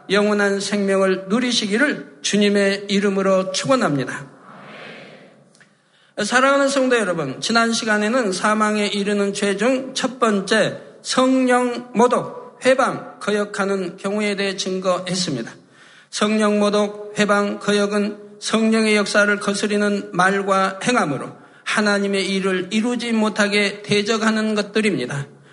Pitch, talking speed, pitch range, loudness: 205 Hz, 275 characters per minute, 200-225 Hz, -19 LUFS